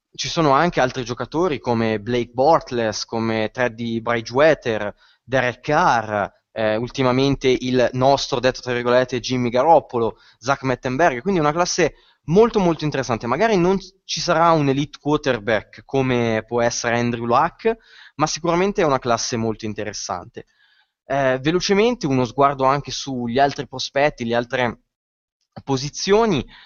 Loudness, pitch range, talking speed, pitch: -20 LUFS, 120-155 Hz, 135 wpm, 130 Hz